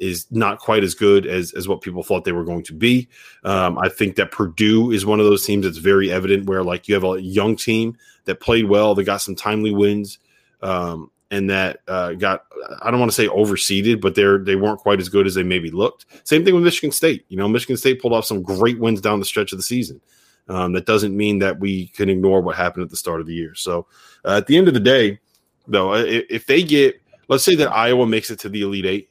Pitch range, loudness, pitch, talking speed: 95-110 Hz, -18 LUFS, 100 Hz, 255 wpm